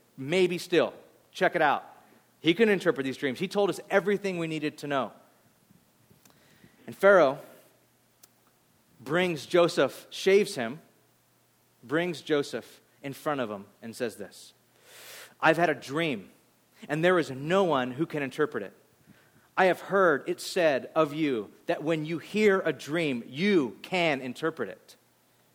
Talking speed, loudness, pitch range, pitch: 150 wpm, -27 LUFS, 145-180 Hz, 160 Hz